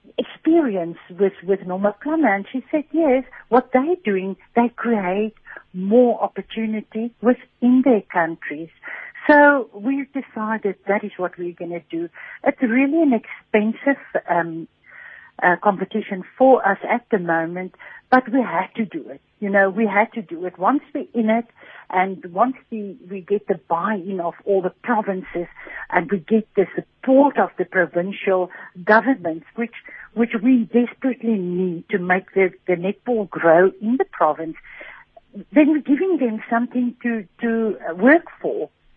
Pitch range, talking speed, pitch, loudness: 185-255 Hz, 155 wpm, 215 Hz, -20 LUFS